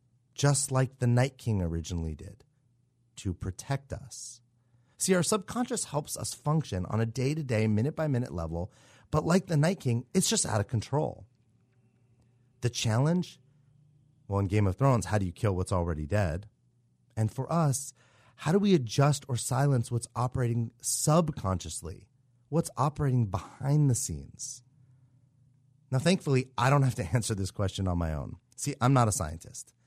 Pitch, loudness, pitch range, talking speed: 125 Hz, -29 LUFS, 110-140 Hz, 165 wpm